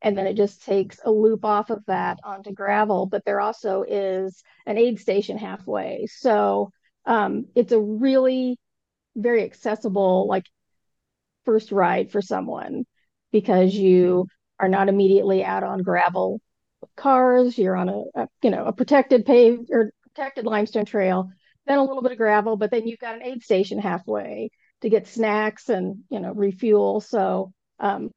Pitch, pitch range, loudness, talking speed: 210 Hz, 195-235 Hz, -22 LUFS, 165 wpm